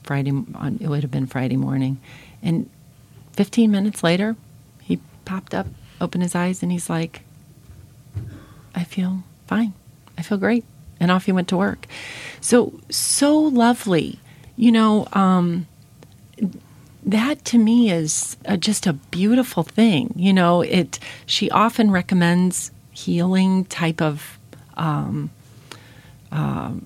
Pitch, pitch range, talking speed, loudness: 170 Hz, 135-200 Hz, 130 wpm, -20 LUFS